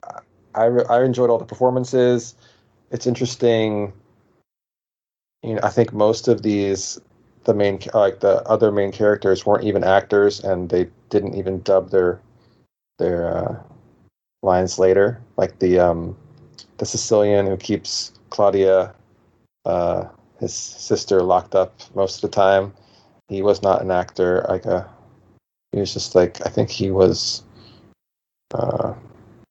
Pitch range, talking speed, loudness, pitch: 95-115 Hz, 140 wpm, -19 LUFS, 105 Hz